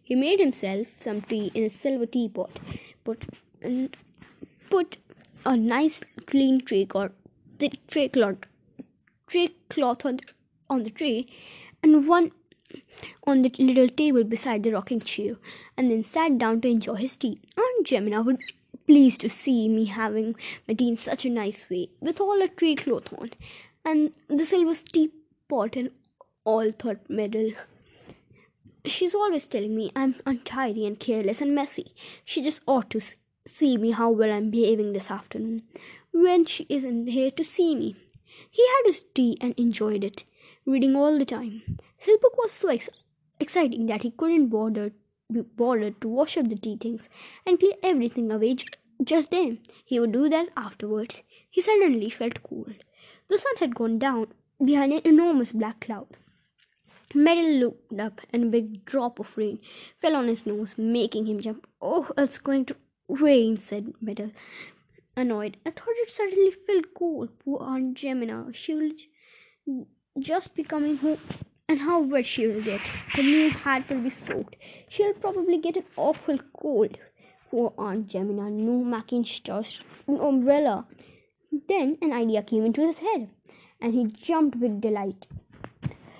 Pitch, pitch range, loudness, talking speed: 255 Hz, 220-310 Hz, -25 LUFS, 165 wpm